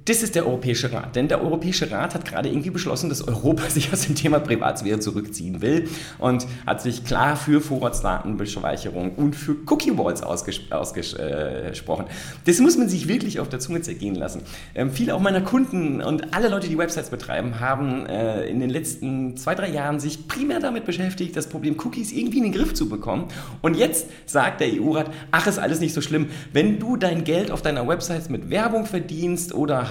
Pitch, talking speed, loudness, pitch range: 155 Hz, 200 wpm, -23 LUFS, 130-185 Hz